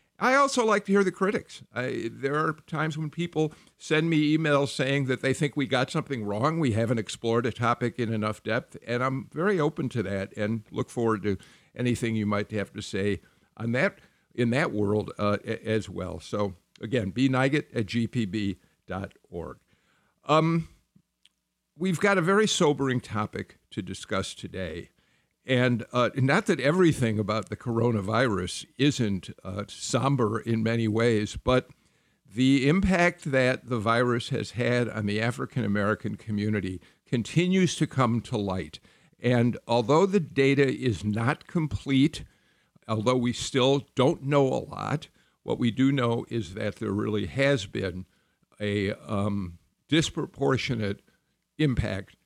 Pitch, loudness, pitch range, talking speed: 120 Hz, -27 LUFS, 105-140 Hz, 150 wpm